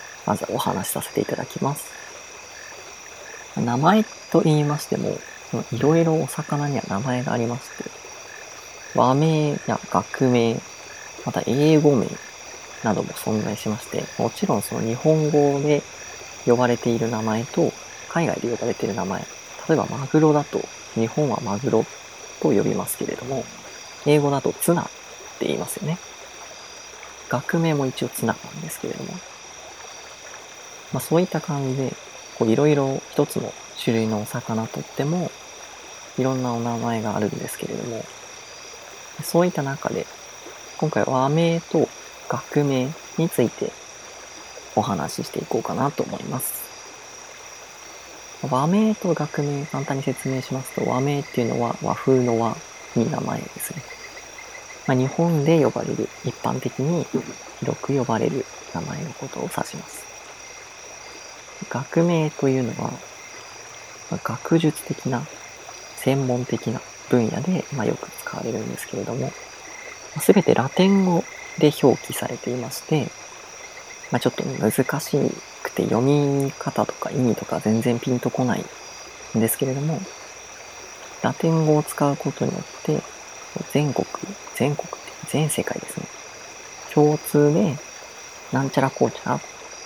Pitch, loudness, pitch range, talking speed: 140 Hz, -23 LUFS, 125-155 Hz, 265 characters per minute